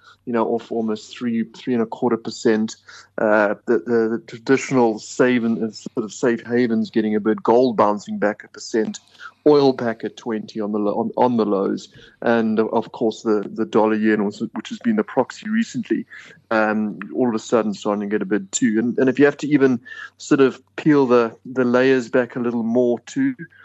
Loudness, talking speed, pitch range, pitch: -20 LUFS, 205 wpm, 110-130 Hz, 115 Hz